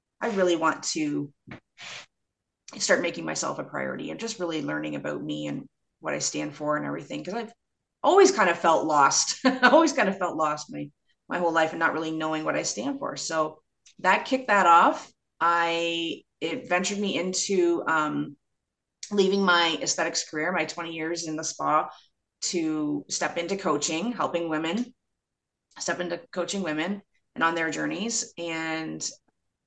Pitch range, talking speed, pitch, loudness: 160-200 Hz, 170 wpm, 170 Hz, -26 LUFS